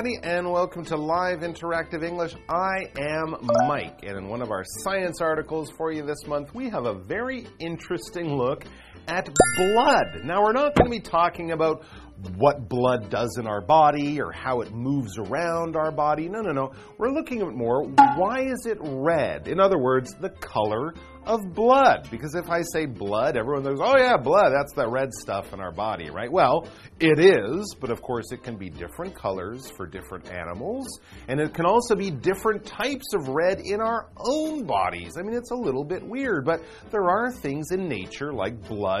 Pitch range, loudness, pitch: 125-195 Hz, -24 LUFS, 160 Hz